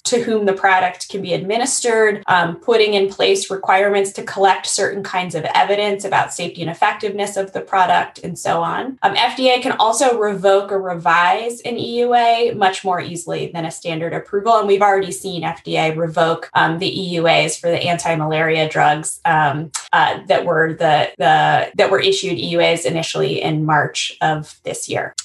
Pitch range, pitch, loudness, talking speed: 165-210 Hz, 190 Hz, -17 LUFS, 175 wpm